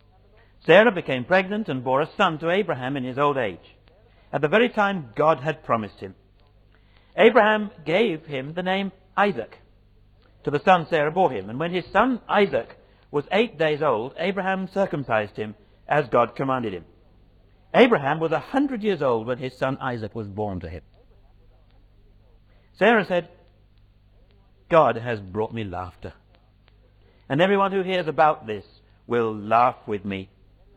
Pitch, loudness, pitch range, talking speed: 115 Hz, -22 LUFS, 100-165 Hz, 155 wpm